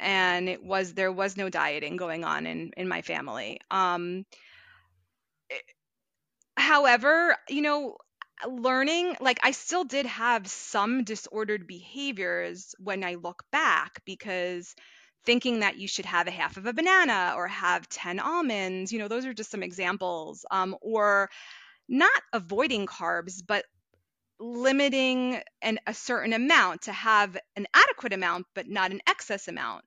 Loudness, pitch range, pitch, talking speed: -27 LUFS, 185-255 Hz, 200 Hz, 150 wpm